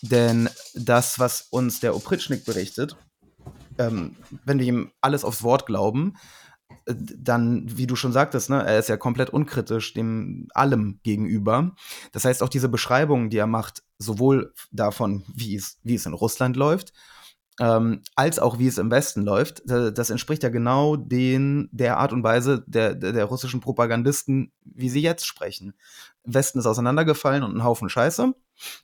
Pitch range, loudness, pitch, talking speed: 115-135 Hz, -23 LUFS, 125 Hz, 170 wpm